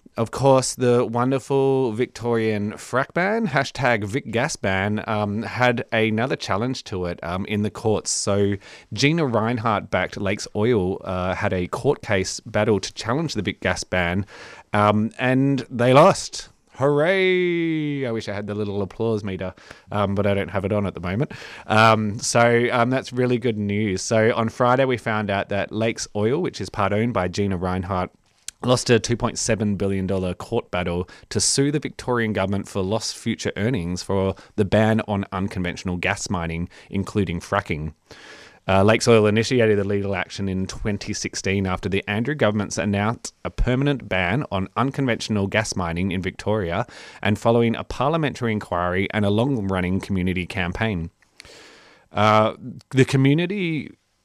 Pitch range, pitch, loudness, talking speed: 95-120 Hz, 105 Hz, -22 LUFS, 160 wpm